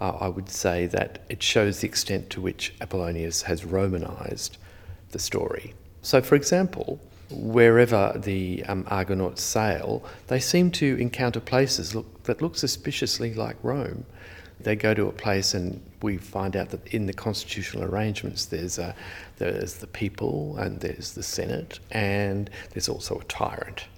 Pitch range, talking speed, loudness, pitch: 95-110 Hz, 155 wpm, -26 LUFS, 100 Hz